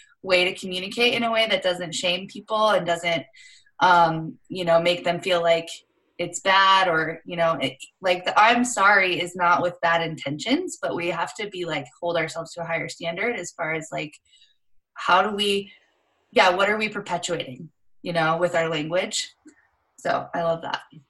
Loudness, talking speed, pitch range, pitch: -22 LUFS, 190 wpm, 165-205 Hz, 175 Hz